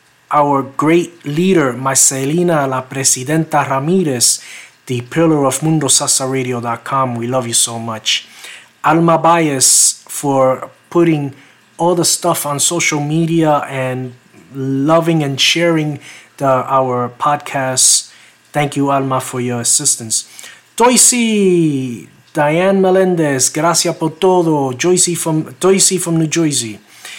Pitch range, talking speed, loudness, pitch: 130-165 Hz, 110 wpm, -13 LUFS, 145 Hz